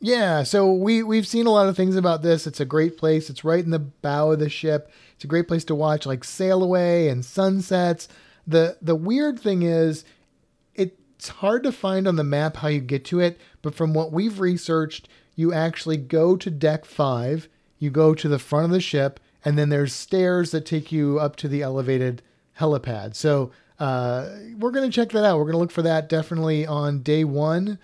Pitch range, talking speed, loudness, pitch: 150-185 Hz, 210 wpm, -22 LUFS, 160 Hz